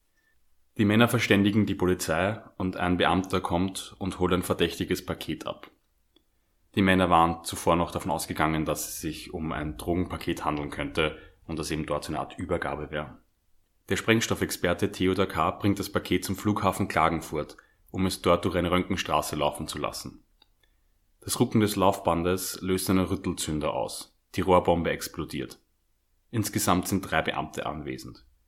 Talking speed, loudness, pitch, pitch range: 155 wpm, -27 LUFS, 90 Hz, 80-95 Hz